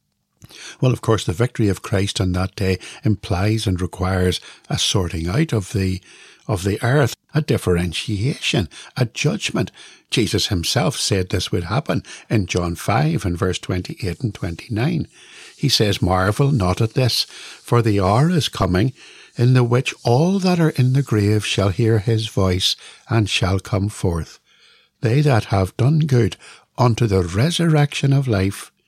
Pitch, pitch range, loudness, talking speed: 110 Hz, 95-125 Hz, -19 LUFS, 165 wpm